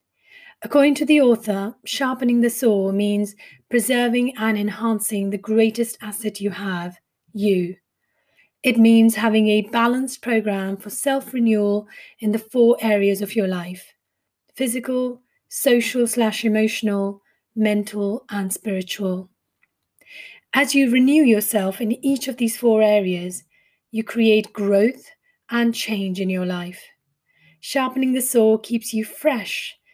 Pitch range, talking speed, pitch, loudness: 205-245 Hz, 125 wpm, 220 Hz, -20 LUFS